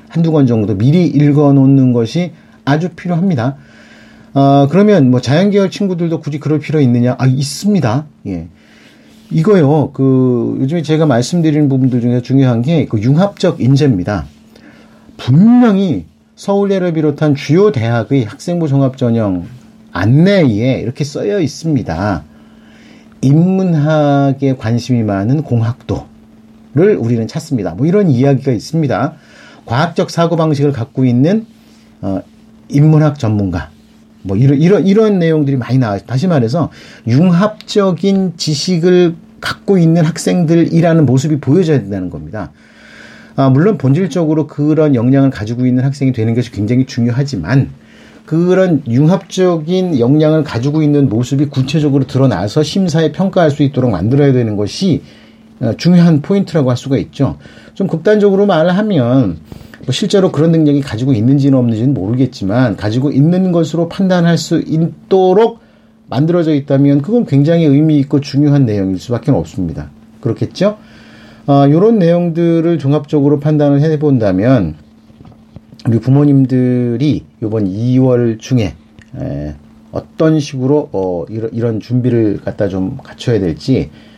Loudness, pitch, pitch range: -12 LUFS, 140 Hz, 120-165 Hz